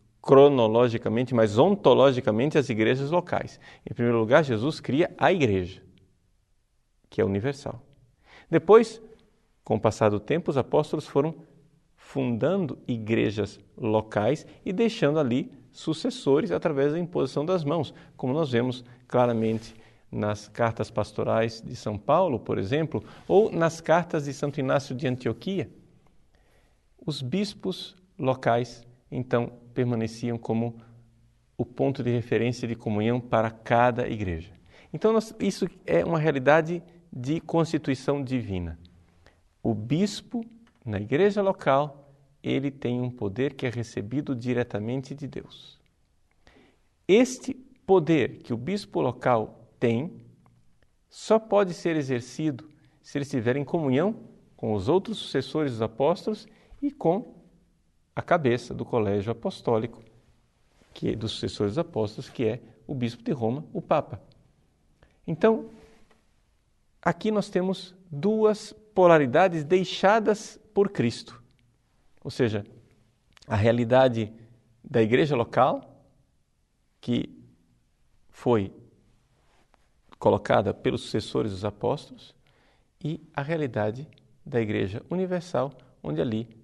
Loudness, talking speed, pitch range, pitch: -26 LUFS, 120 wpm, 115-160 Hz, 130 Hz